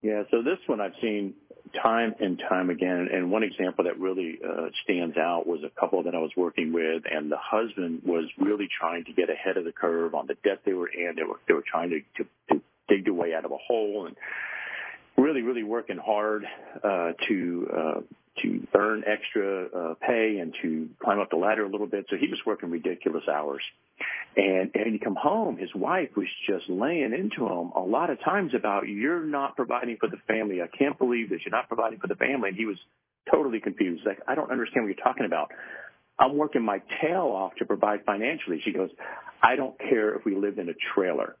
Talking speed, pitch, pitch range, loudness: 220 wpm, 105 Hz, 90-140 Hz, -28 LUFS